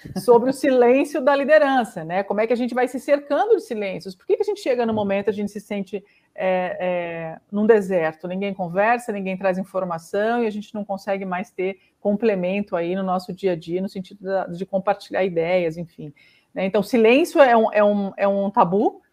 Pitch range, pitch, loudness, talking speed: 185-235 Hz, 200 Hz, -21 LUFS, 215 wpm